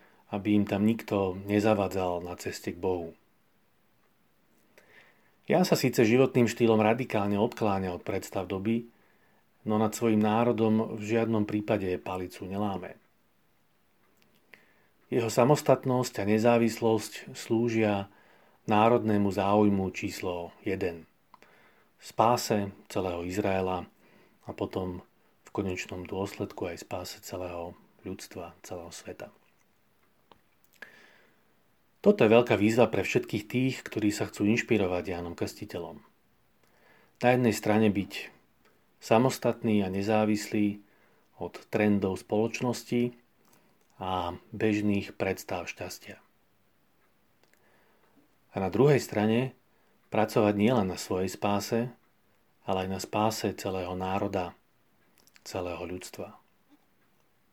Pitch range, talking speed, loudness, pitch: 95-115 Hz, 100 wpm, -28 LUFS, 105 Hz